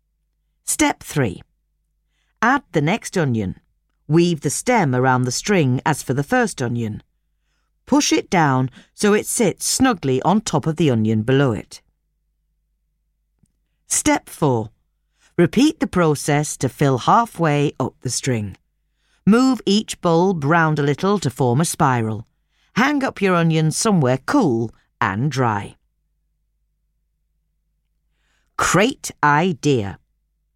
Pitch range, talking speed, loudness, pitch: 130-195 Hz, 120 wpm, -19 LUFS, 155 Hz